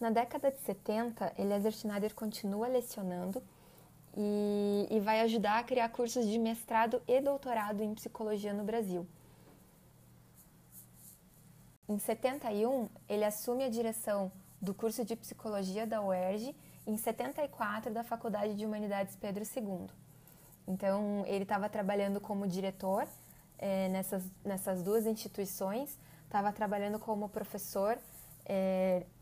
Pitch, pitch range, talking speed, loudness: 210 Hz, 195-230 Hz, 120 wpm, -36 LUFS